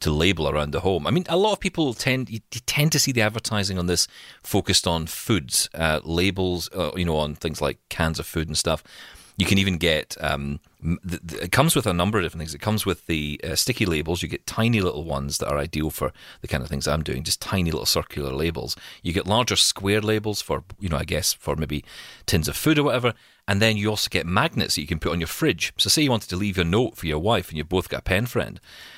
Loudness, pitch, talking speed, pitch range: -23 LUFS, 90 Hz, 260 wpm, 80-110 Hz